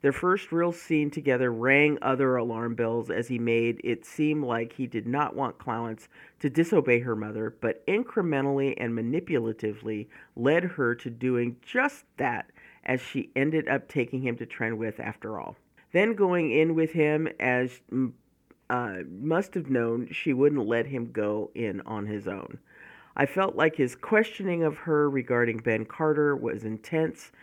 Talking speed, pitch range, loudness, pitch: 165 wpm, 115-155 Hz, -27 LUFS, 130 Hz